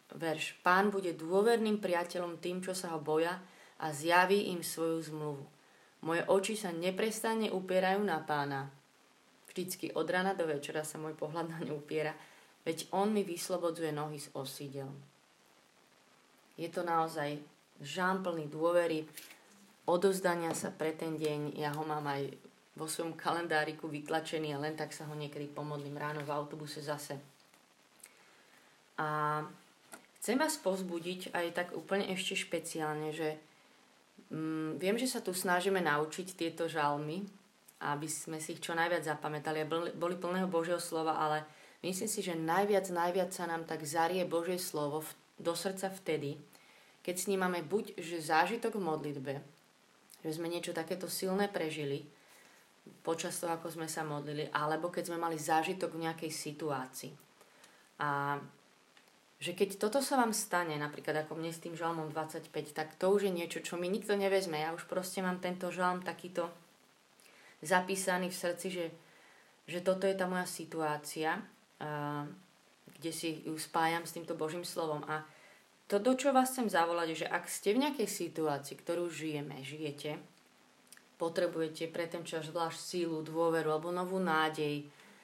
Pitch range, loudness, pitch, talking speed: 155-180 Hz, -36 LUFS, 165 Hz, 160 wpm